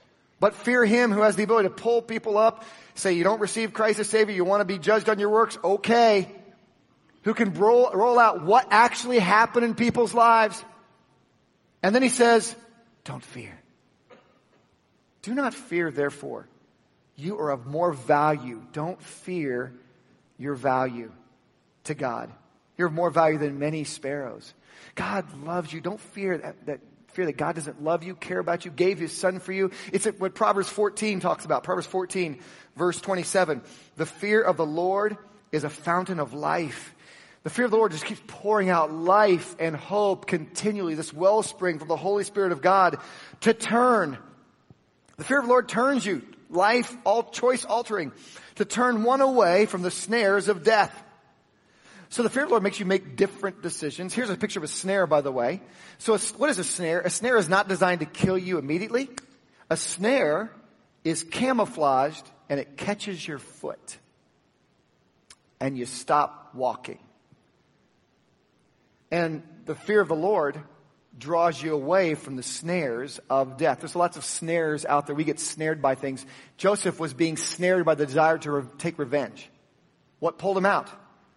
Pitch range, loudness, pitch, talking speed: 155-215 Hz, -25 LUFS, 185 Hz, 175 wpm